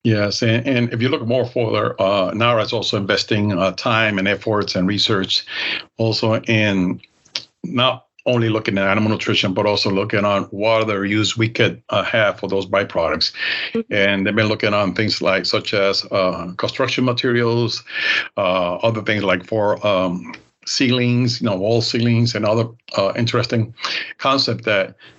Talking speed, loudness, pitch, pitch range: 165 wpm, -18 LUFS, 110 Hz, 100-115 Hz